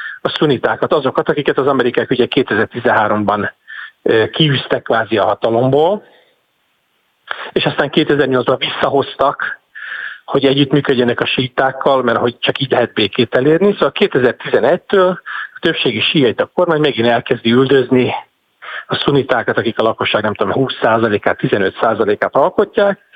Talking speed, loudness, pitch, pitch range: 120 wpm, -14 LUFS, 135 Hz, 125-175 Hz